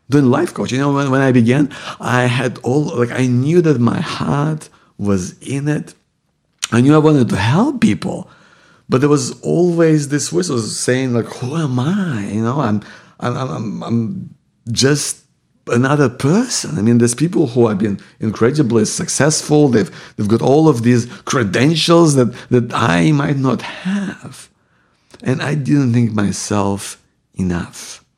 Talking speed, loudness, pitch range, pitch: 160 wpm, -15 LUFS, 115-150 Hz, 130 Hz